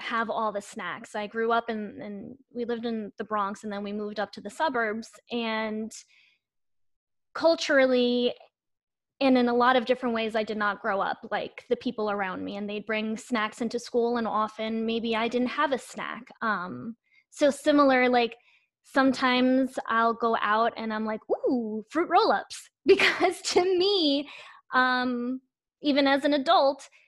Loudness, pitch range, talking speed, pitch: -26 LUFS, 220-270 Hz, 175 wpm, 240 Hz